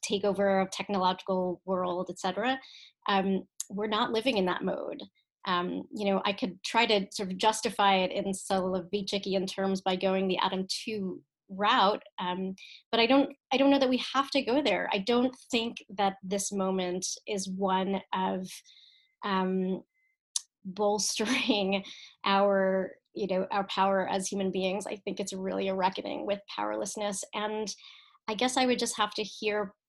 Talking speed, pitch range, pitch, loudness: 165 wpm, 190-220 Hz, 200 Hz, -30 LUFS